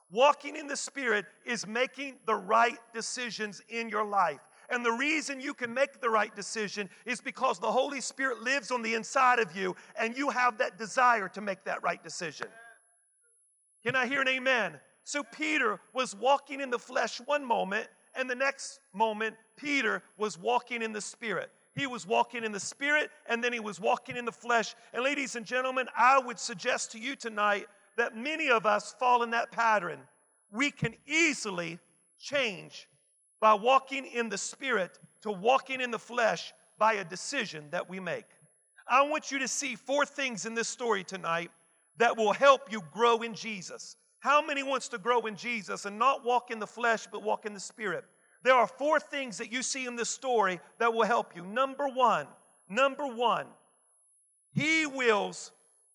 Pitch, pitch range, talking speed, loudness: 235 Hz, 215-265 Hz, 185 wpm, -30 LUFS